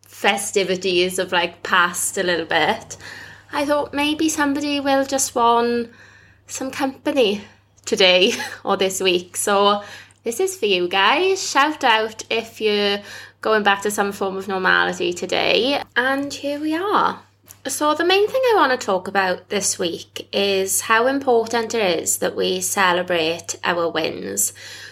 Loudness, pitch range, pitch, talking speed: -19 LUFS, 190-285 Hz, 220 Hz, 150 wpm